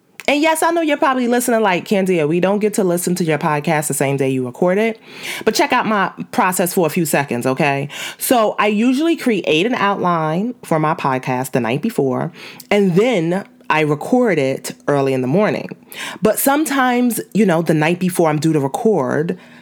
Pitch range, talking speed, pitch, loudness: 155-225 Hz, 200 wpm, 185 Hz, -17 LUFS